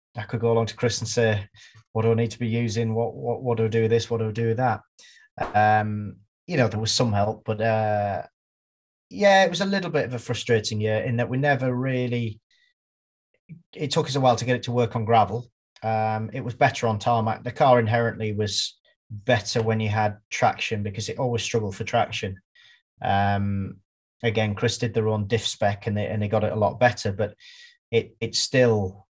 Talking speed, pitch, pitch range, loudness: 220 wpm, 115 Hz, 110-120 Hz, -24 LUFS